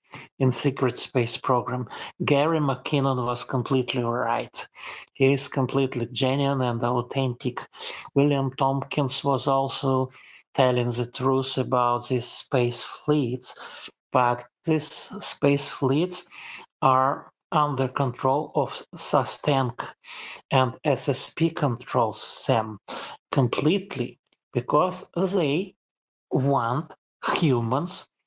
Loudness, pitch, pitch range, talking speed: -25 LUFS, 135 Hz, 125-140 Hz, 95 wpm